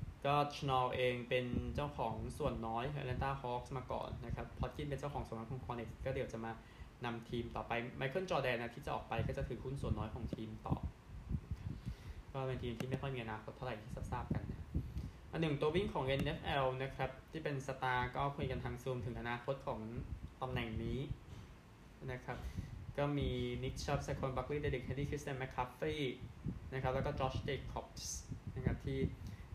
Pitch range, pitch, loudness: 115-135 Hz, 125 Hz, -42 LUFS